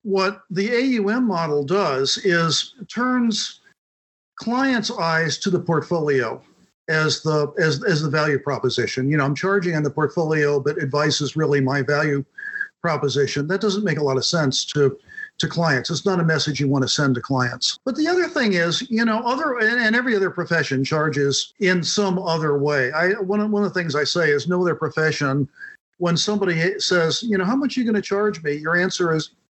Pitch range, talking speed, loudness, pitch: 145-205 Hz, 205 wpm, -20 LUFS, 170 Hz